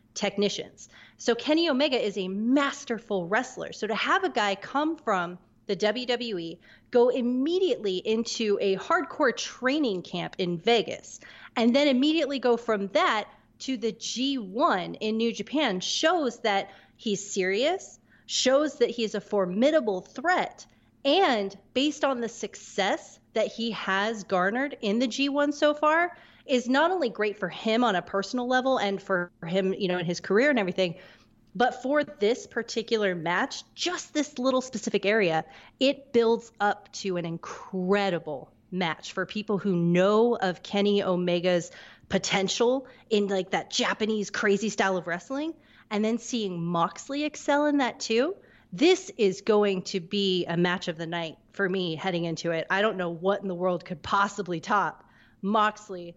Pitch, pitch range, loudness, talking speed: 215 Hz, 190-260 Hz, -27 LUFS, 160 wpm